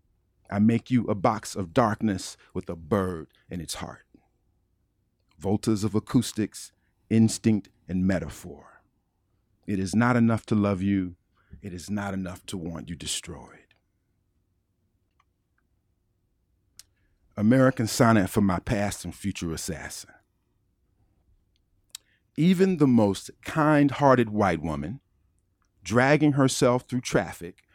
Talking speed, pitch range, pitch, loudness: 115 wpm, 90-110 Hz, 100 Hz, -25 LUFS